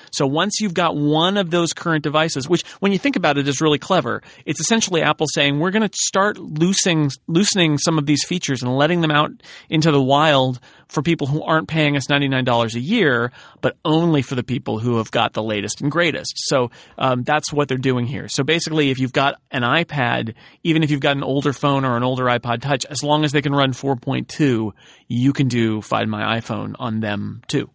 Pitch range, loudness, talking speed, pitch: 125-160 Hz, -19 LUFS, 220 wpm, 145 Hz